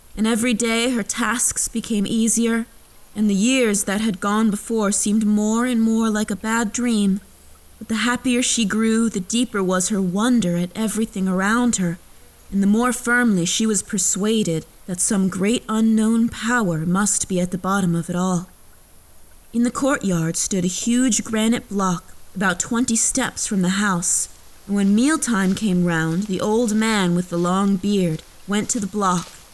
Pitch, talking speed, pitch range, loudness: 210 Hz, 175 wpm, 185-230 Hz, -20 LUFS